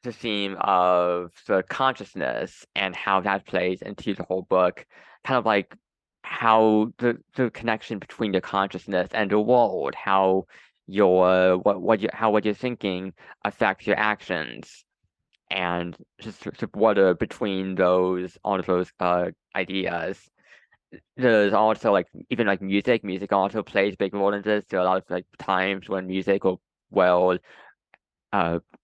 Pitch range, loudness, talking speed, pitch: 90-105 Hz, -24 LUFS, 160 wpm, 95 Hz